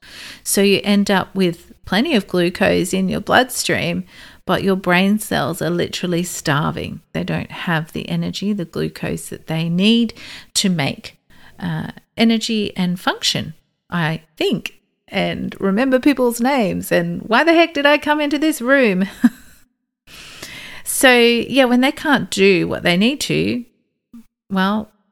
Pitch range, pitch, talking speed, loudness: 175-245 Hz, 200 Hz, 145 wpm, -17 LUFS